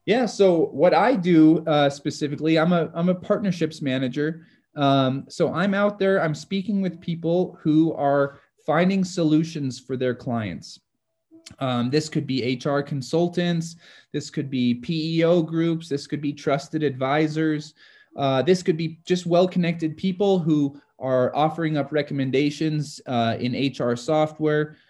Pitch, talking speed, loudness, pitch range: 155 Hz, 150 wpm, -23 LUFS, 140-170 Hz